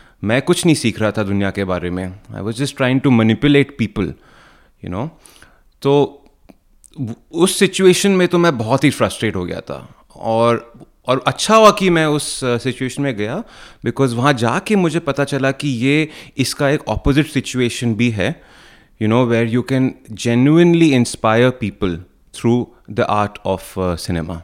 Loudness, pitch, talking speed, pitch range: -16 LUFS, 125 Hz, 170 wpm, 110-145 Hz